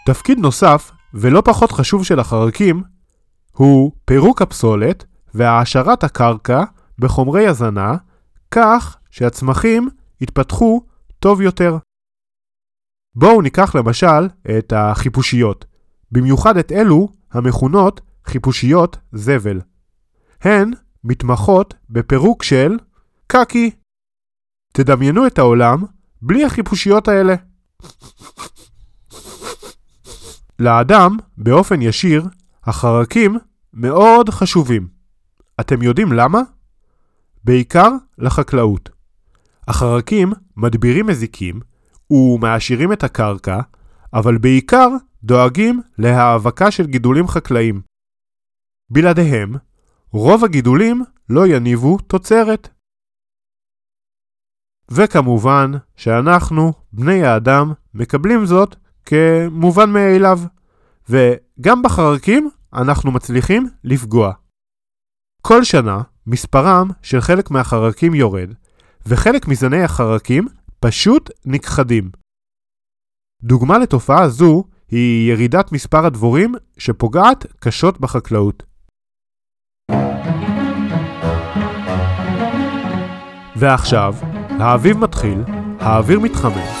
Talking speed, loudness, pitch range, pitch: 75 wpm, -14 LUFS, 115-185 Hz, 130 Hz